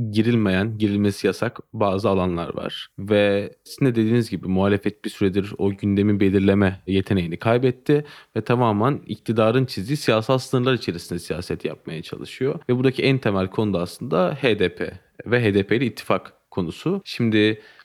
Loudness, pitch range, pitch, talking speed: -22 LUFS, 100-120 Hz, 105 Hz, 140 wpm